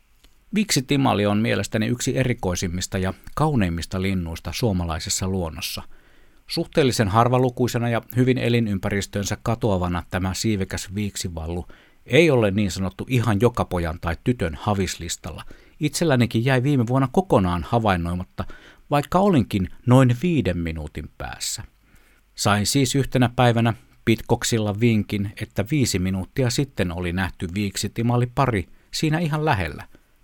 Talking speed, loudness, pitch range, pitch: 115 wpm, -22 LUFS, 95-125 Hz, 105 Hz